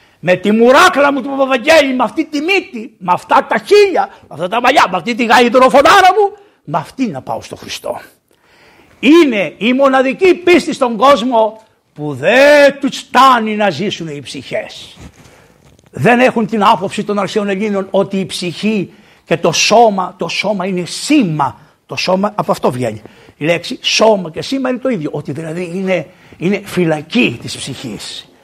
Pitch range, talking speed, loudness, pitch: 180-265 Hz, 170 wpm, -12 LUFS, 215 Hz